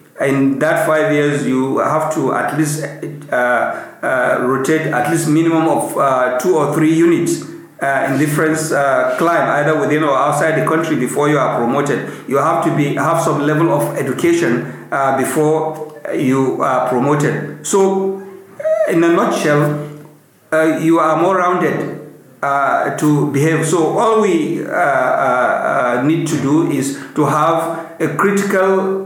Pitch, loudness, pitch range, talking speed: 155 Hz, -15 LUFS, 145-165 Hz, 155 wpm